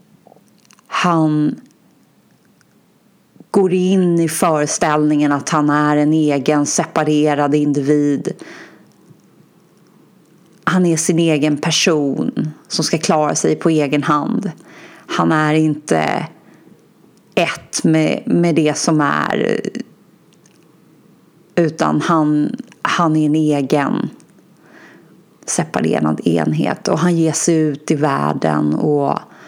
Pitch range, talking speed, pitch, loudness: 150-170 Hz, 100 wpm, 155 Hz, -16 LUFS